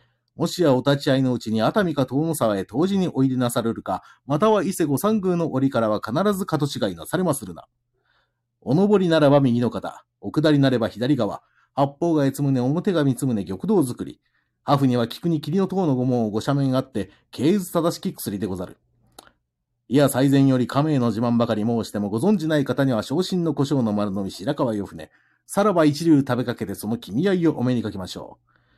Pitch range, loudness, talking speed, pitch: 115-160 Hz, -22 LUFS, 385 characters per minute, 135 Hz